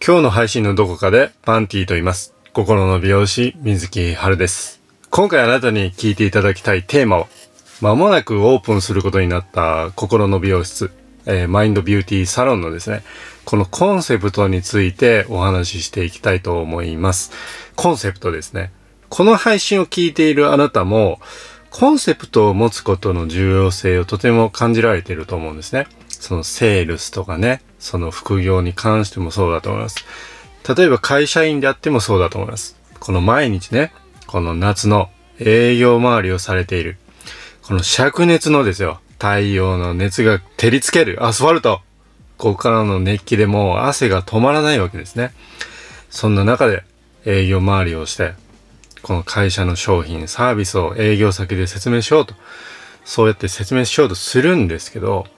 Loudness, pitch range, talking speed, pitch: -16 LUFS, 95-115 Hz, 360 characters per minute, 100 Hz